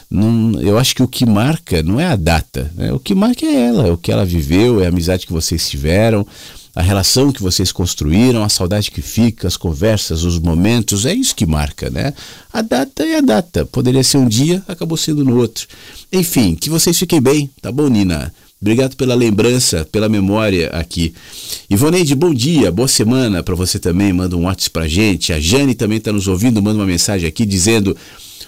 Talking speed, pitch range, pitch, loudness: 205 wpm, 90-130 Hz, 105 Hz, -14 LUFS